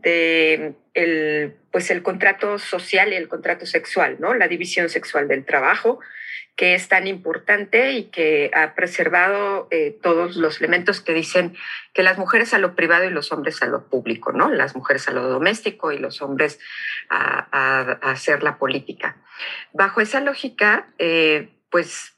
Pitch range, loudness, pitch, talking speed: 165-205 Hz, -19 LUFS, 180 Hz, 170 wpm